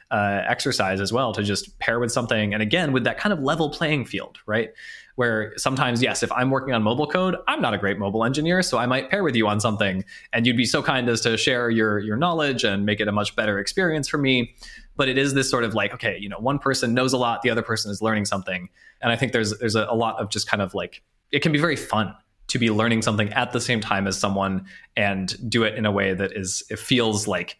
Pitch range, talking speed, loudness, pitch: 105-130 Hz, 265 wpm, -23 LUFS, 115 Hz